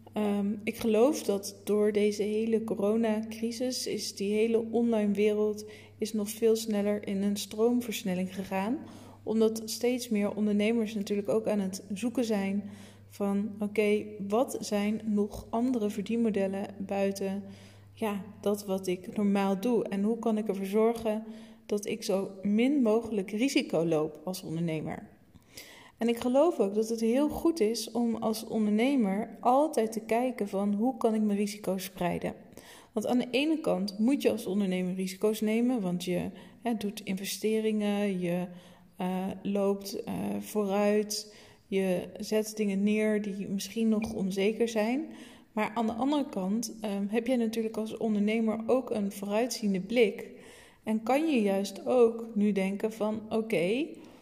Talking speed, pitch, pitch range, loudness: 150 wpm, 210 Hz, 200-225 Hz, -30 LUFS